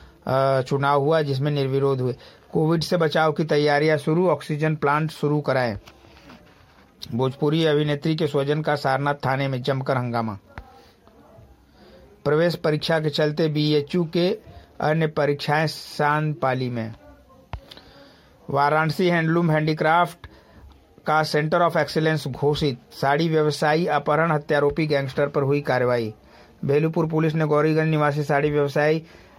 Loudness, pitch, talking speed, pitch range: -22 LUFS, 150 Hz, 120 wpm, 140-155 Hz